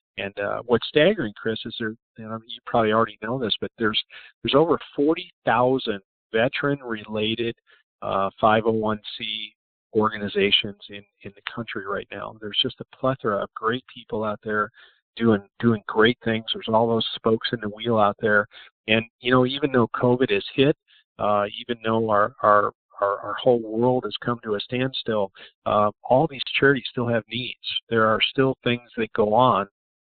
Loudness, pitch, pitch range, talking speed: -23 LUFS, 115 Hz, 105-125 Hz, 175 wpm